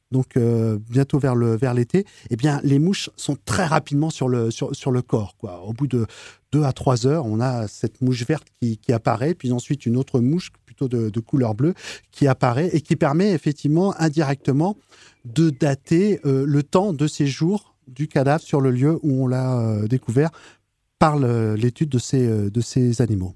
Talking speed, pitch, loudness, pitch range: 200 wpm, 135 Hz, -21 LUFS, 120-150 Hz